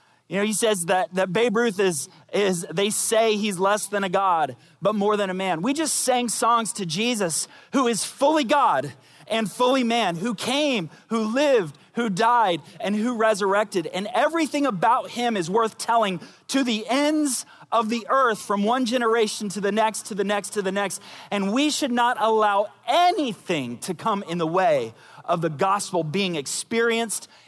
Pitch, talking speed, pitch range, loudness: 215 Hz, 185 wpm, 195-235 Hz, -23 LUFS